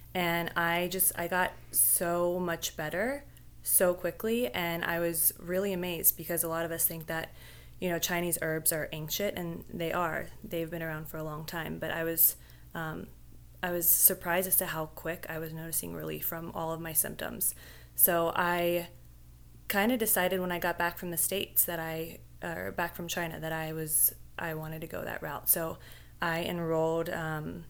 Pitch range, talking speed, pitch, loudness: 155-175 Hz, 195 wpm, 165 Hz, -30 LUFS